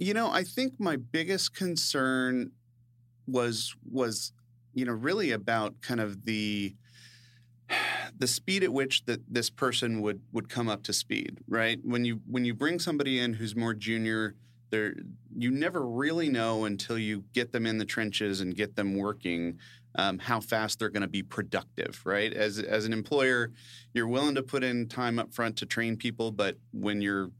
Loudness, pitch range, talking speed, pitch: -30 LUFS, 110-125 Hz, 180 wpm, 120 Hz